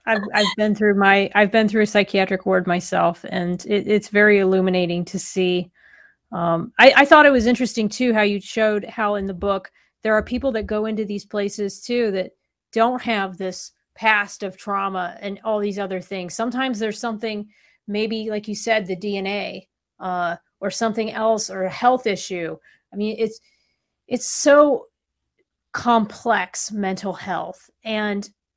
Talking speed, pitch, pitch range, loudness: 170 wpm, 210 Hz, 190-225 Hz, -20 LUFS